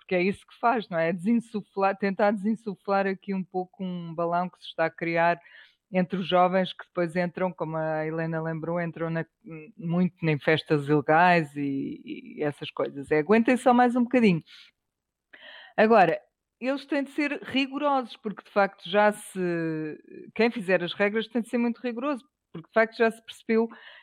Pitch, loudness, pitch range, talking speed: 190 Hz, -26 LUFS, 165-230 Hz, 180 wpm